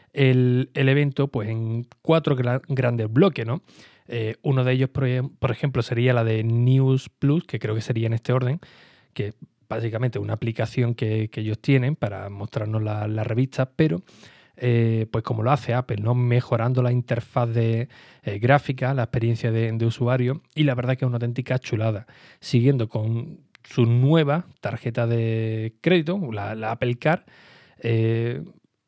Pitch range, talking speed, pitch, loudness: 115-135 Hz, 170 wpm, 125 Hz, -23 LUFS